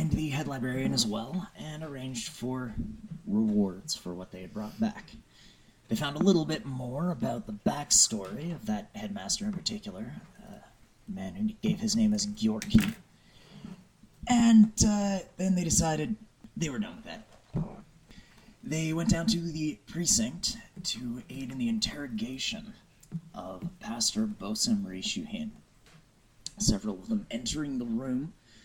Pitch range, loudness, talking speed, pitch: 155-215 Hz, -30 LUFS, 145 wpm, 195 Hz